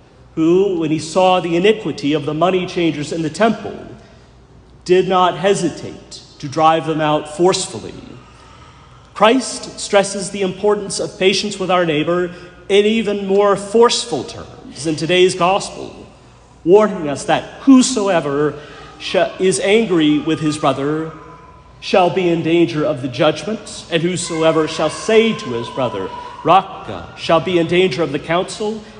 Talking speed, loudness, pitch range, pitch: 145 wpm, -16 LUFS, 160-200 Hz, 180 Hz